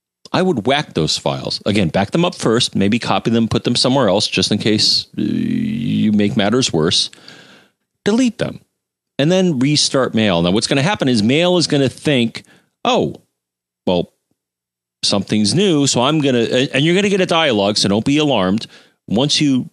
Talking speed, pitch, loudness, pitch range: 190 wpm, 125 Hz, -16 LUFS, 105-150 Hz